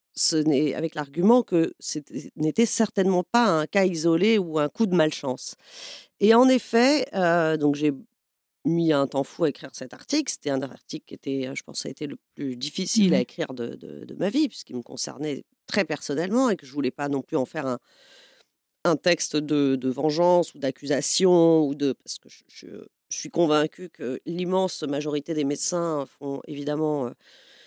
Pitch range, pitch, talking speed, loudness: 145-185 Hz, 155 Hz, 195 wpm, -24 LUFS